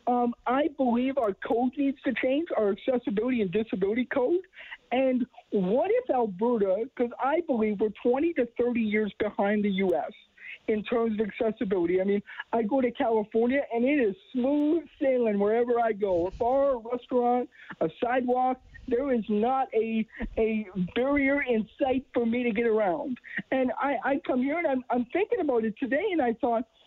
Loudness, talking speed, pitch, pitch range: -27 LUFS, 180 wpm, 245 Hz, 220-265 Hz